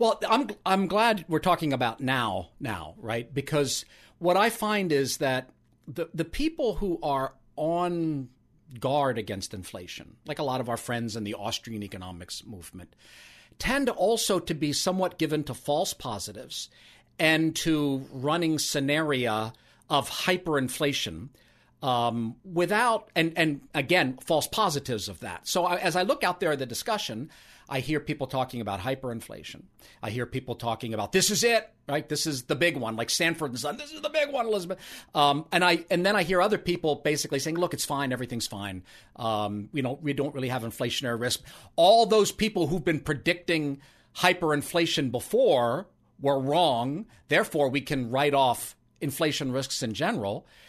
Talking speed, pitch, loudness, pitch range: 170 wpm, 145 Hz, -27 LUFS, 125-175 Hz